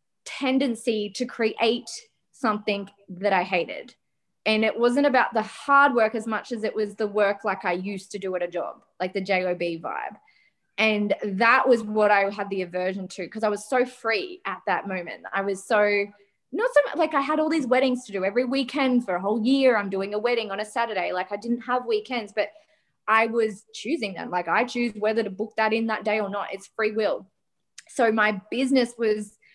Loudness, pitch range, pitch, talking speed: -24 LUFS, 200-245 Hz, 220 Hz, 220 wpm